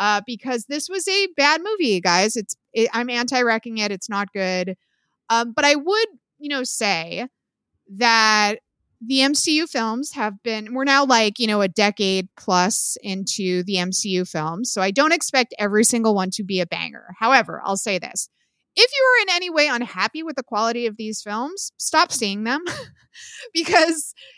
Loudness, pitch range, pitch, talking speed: -20 LUFS, 200-285 Hz, 230 Hz, 180 wpm